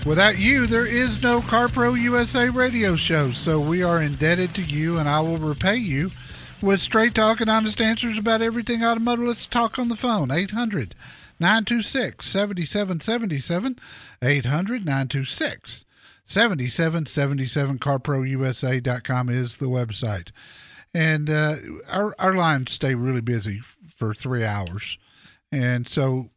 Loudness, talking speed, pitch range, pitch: -22 LUFS, 130 wpm, 135-225 Hz, 165 Hz